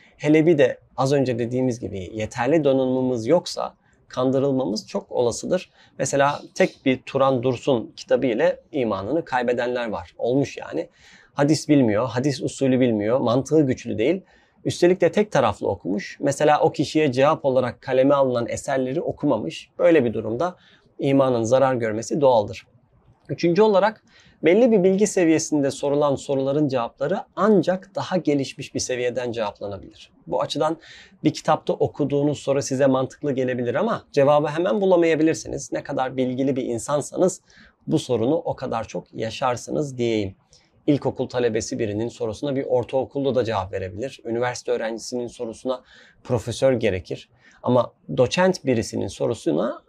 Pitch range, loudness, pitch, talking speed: 125-150 Hz, -22 LUFS, 135 Hz, 135 wpm